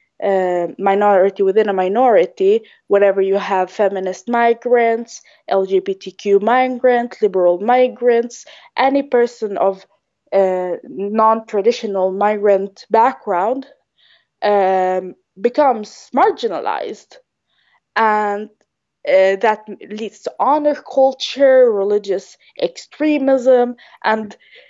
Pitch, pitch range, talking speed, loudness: 220 Hz, 195-255 Hz, 85 wpm, -16 LUFS